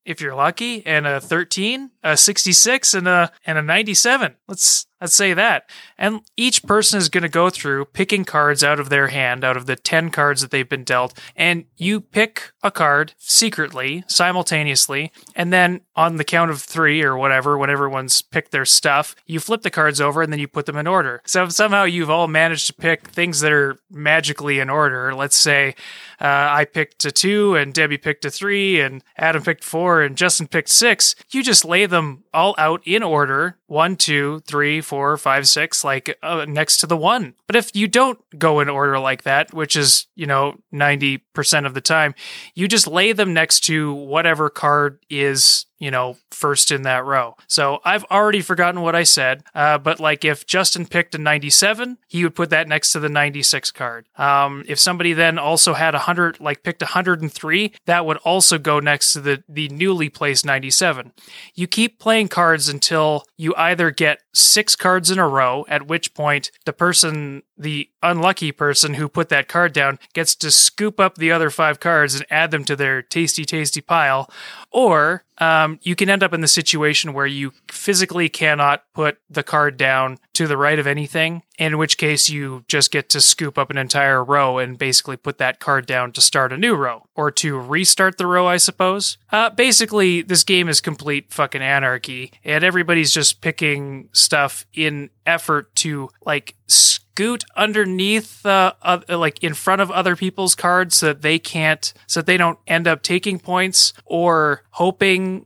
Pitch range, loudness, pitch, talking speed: 145-180 Hz, -16 LUFS, 155 Hz, 195 wpm